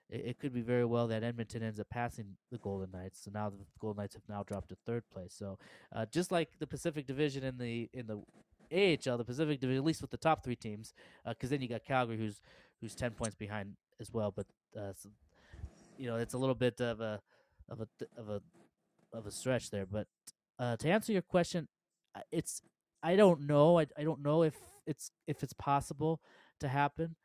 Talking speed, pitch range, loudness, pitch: 220 wpm, 105-145 Hz, -36 LUFS, 120 Hz